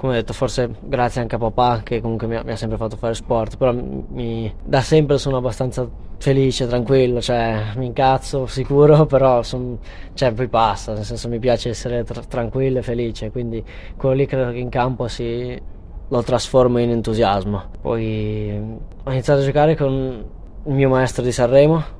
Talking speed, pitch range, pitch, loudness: 185 wpm, 115-130 Hz, 120 Hz, -19 LUFS